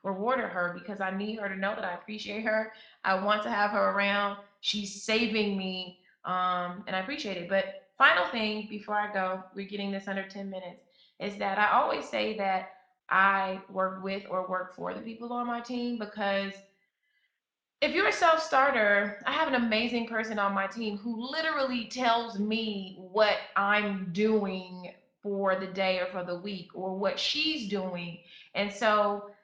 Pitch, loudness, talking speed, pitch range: 200 Hz, -29 LUFS, 180 wpm, 190-220 Hz